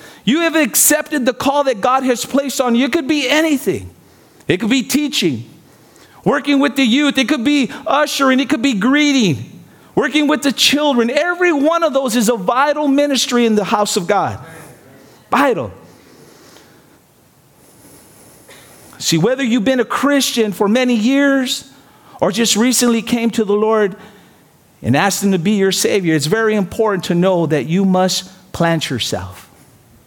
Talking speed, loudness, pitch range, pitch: 165 wpm, -15 LUFS, 185-280 Hz, 240 Hz